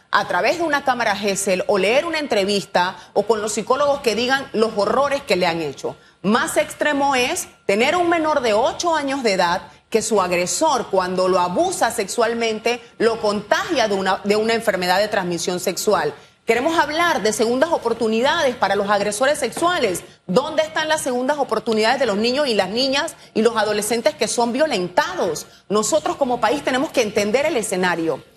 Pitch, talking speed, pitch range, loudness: 230 Hz, 180 wpm, 200-280 Hz, -19 LUFS